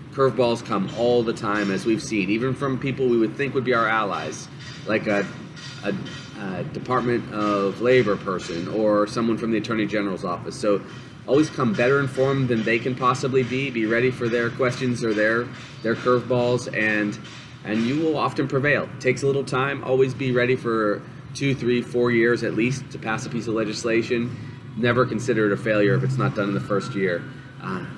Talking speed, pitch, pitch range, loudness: 200 wpm, 120 Hz, 110-130 Hz, -23 LUFS